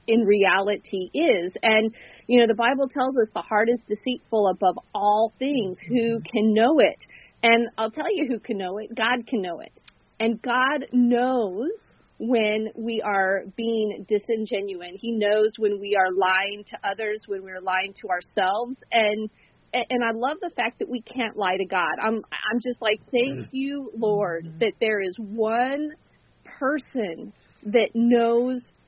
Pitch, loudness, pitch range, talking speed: 225 Hz, -24 LUFS, 205-245 Hz, 165 wpm